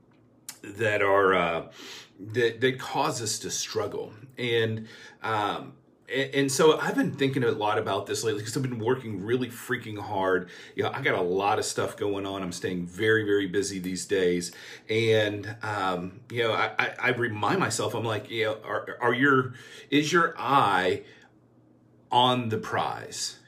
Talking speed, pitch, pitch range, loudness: 175 wpm, 110 Hz, 100-125 Hz, -27 LUFS